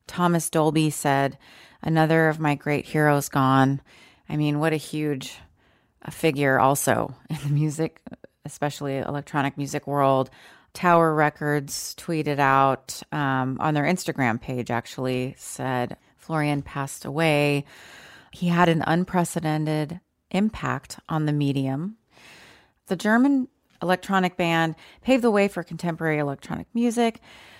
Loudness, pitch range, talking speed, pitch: -24 LUFS, 140-165 Hz, 125 wpm, 150 Hz